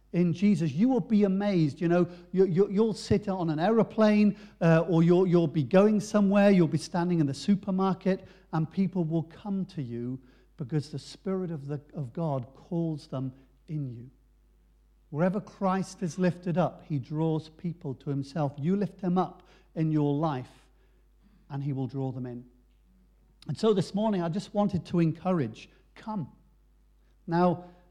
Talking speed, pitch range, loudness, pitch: 170 wpm, 145-190 Hz, -28 LUFS, 170 Hz